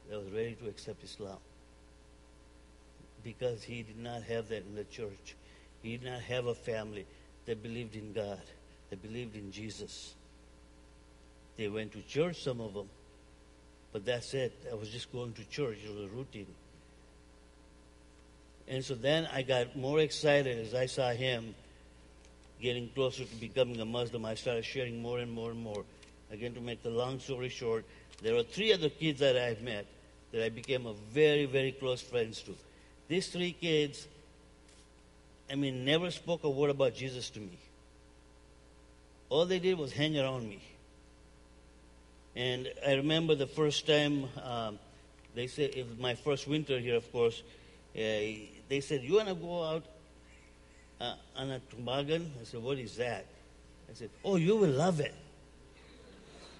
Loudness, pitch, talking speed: -35 LUFS, 115 Hz, 170 wpm